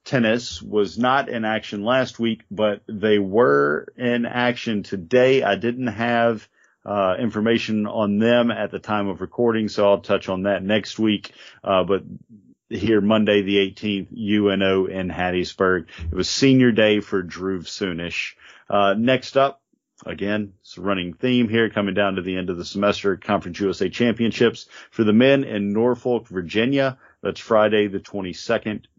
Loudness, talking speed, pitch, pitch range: -21 LUFS, 160 wpm, 105 Hz, 95-115 Hz